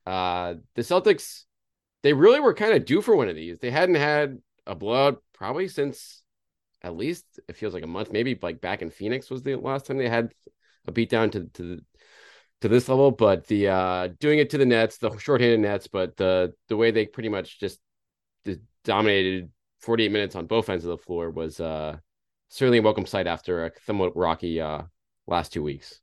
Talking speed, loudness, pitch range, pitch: 205 wpm, -24 LUFS, 90-120 Hz, 105 Hz